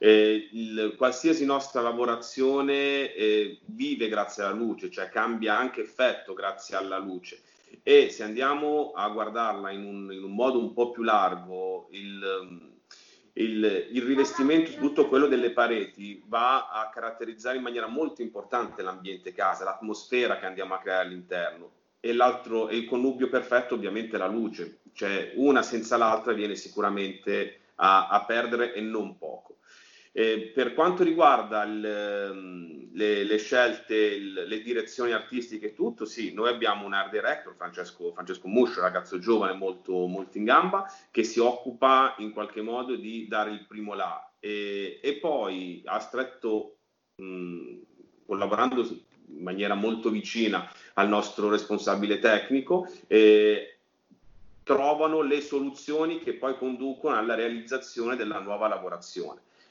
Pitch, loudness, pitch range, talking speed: 115 Hz, -27 LUFS, 100-130 Hz, 140 wpm